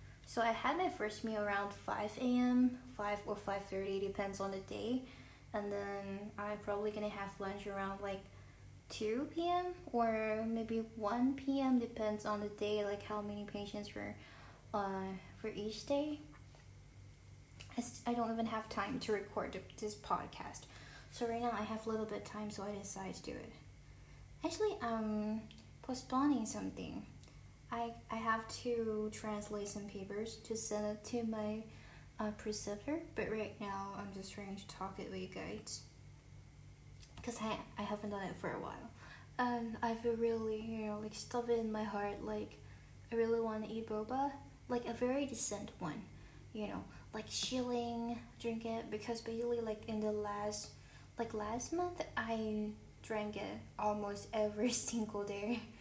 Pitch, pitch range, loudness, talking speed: 215 Hz, 200-230 Hz, -41 LUFS, 165 wpm